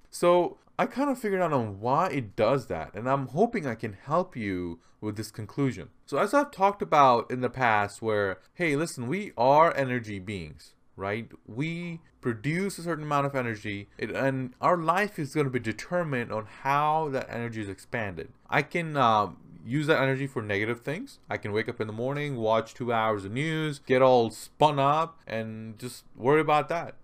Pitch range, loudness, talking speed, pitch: 110-155 Hz, -27 LUFS, 195 wpm, 130 Hz